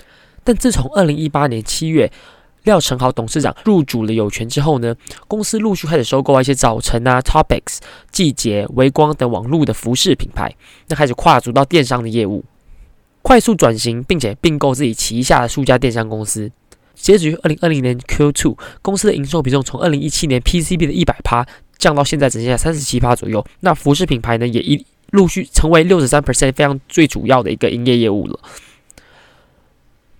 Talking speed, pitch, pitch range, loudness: 330 characters per minute, 140 Hz, 120-160 Hz, -15 LUFS